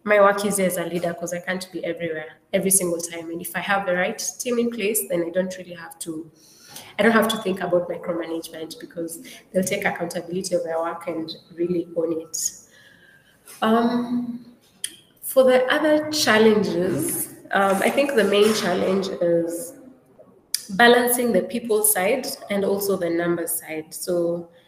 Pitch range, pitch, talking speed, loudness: 170-215 Hz, 185 Hz, 170 wpm, -22 LUFS